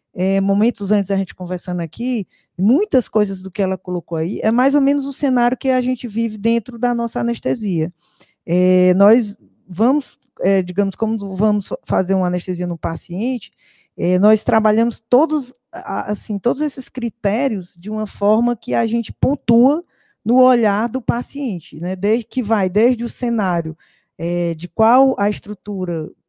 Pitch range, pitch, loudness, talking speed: 185-245 Hz, 215 Hz, -18 LUFS, 160 wpm